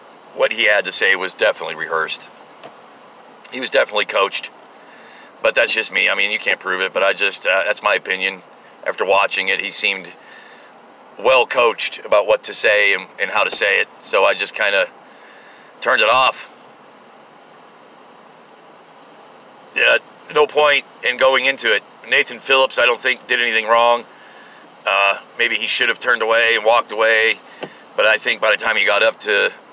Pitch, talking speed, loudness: 150 Hz, 180 wpm, -16 LUFS